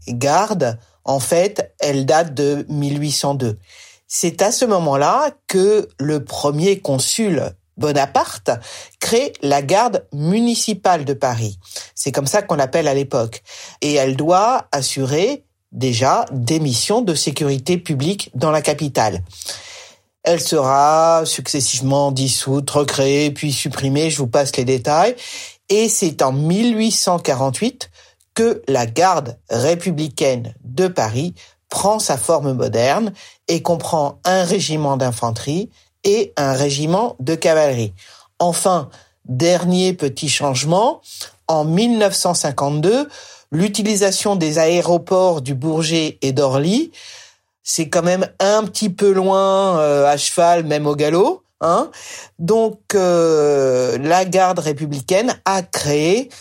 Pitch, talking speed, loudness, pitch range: 155 Hz, 120 wpm, -17 LUFS, 140-185 Hz